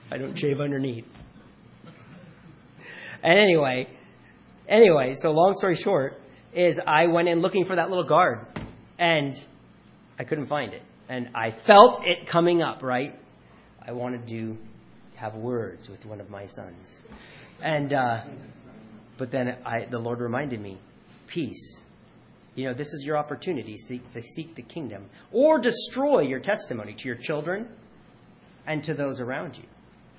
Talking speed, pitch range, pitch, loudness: 145 wpm, 115-170 Hz, 130 Hz, -24 LUFS